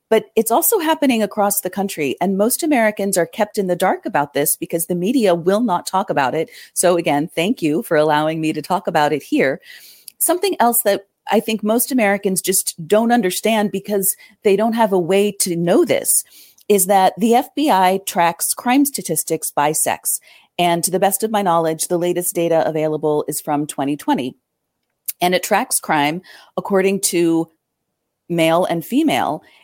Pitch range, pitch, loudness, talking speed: 165-210 Hz, 185 Hz, -17 LUFS, 180 wpm